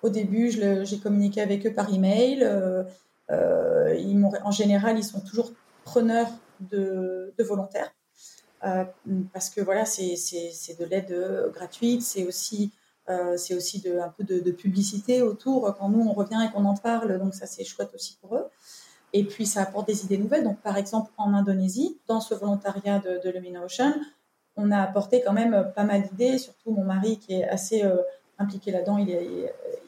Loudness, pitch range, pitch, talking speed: -26 LUFS, 190-225 Hz, 200 Hz, 195 wpm